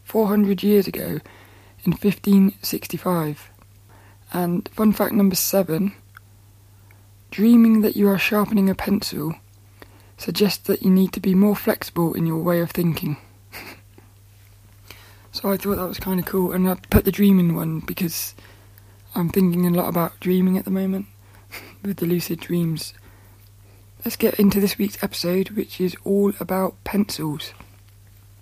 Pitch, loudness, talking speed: 175 Hz, -21 LUFS, 150 wpm